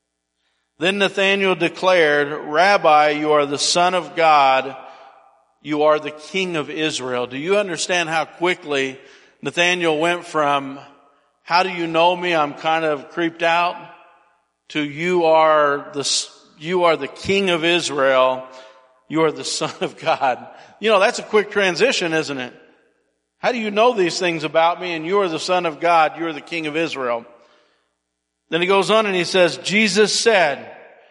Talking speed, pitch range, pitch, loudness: 170 wpm, 140-180 Hz, 160 Hz, -18 LUFS